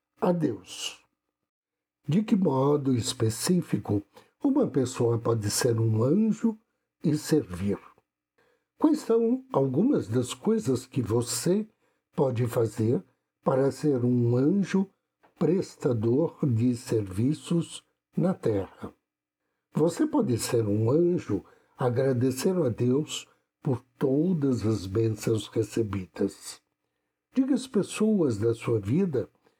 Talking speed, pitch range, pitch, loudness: 105 wpm, 115-175 Hz, 130 Hz, -27 LUFS